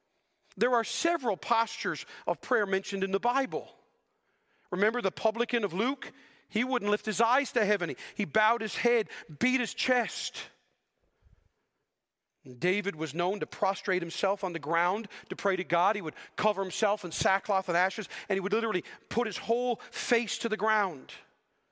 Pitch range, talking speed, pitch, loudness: 190-235 Hz, 170 wpm, 210 Hz, -30 LUFS